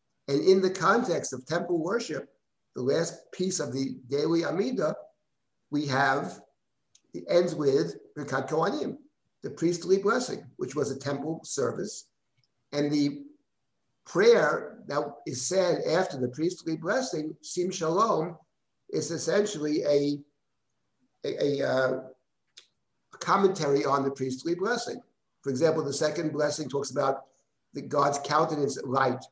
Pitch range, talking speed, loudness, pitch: 140-170 Hz, 125 wpm, -28 LUFS, 150 Hz